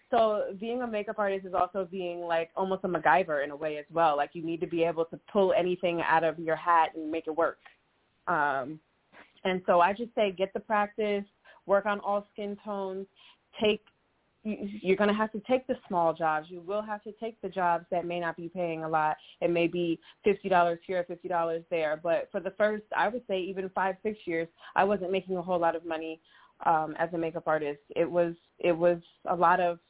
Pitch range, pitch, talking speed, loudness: 165-205 Hz, 180 Hz, 225 wpm, -29 LUFS